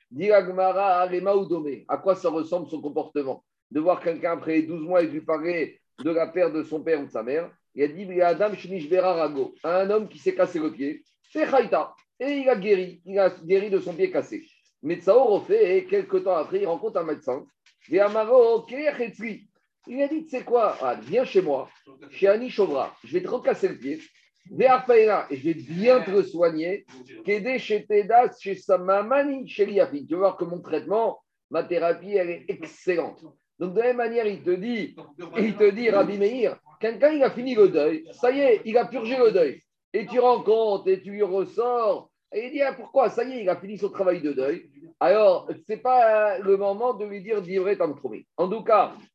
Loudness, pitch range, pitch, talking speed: -24 LUFS, 175-255 Hz, 200 Hz, 200 wpm